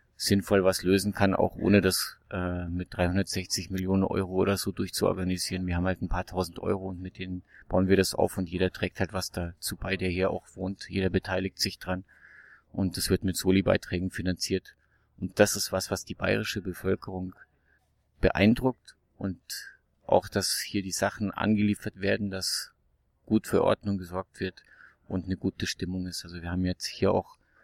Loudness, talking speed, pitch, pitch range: -29 LUFS, 180 wpm, 95 Hz, 90-100 Hz